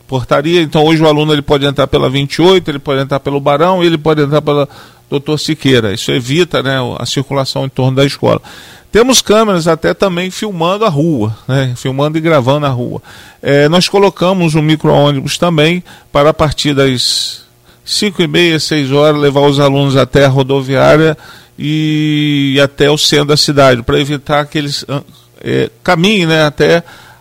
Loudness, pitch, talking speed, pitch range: -11 LUFS, 145 Hz, 170 wpm, 140-160 Hz